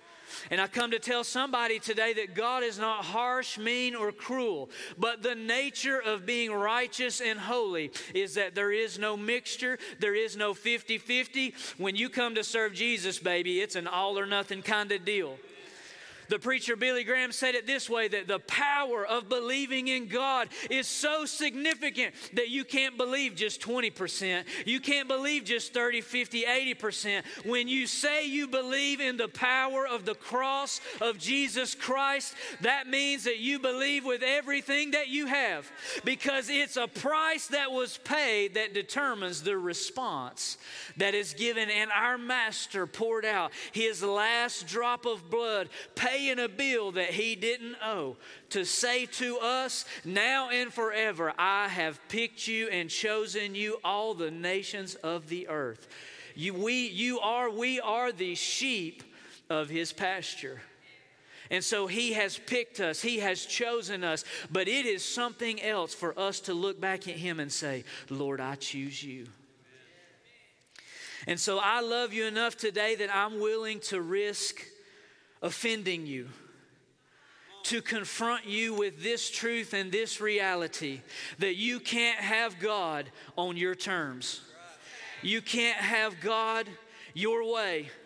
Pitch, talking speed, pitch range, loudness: 225 Hz, 155 wpm, 200-255 Hz, -30 LUFS